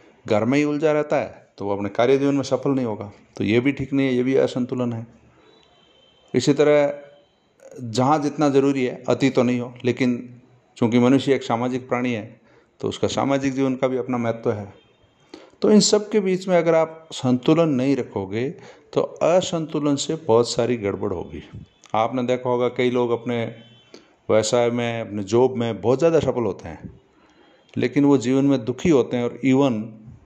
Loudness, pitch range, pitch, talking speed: -21 LUFS, 120-140 Hz, 125 Hz, 190 wpm